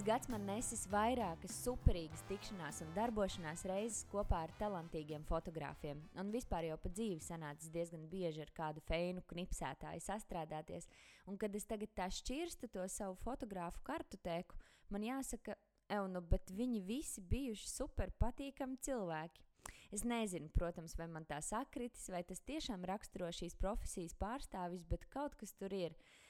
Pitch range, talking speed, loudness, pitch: 170-225 Hz, 140 wpm, -45 LUFS, 190 Hz